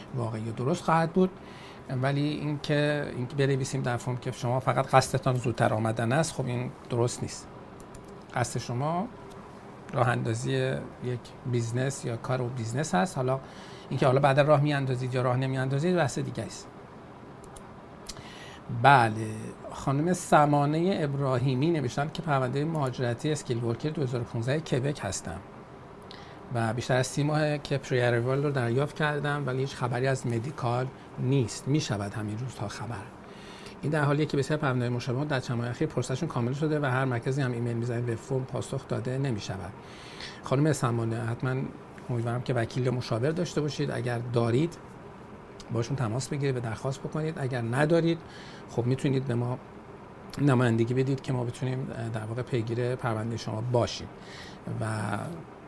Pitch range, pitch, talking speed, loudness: 120-145 Hz, 130 Hz, 155 wpm, -29 LUFS